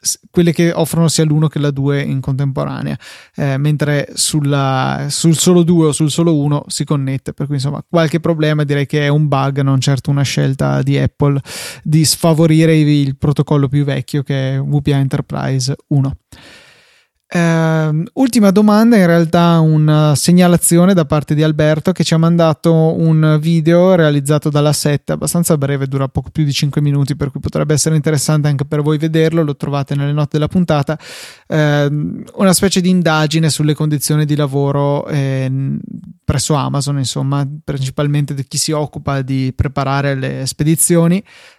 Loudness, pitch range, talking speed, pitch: -14 LUFS, 140-160 Hz, 165 wpm, 150 Hz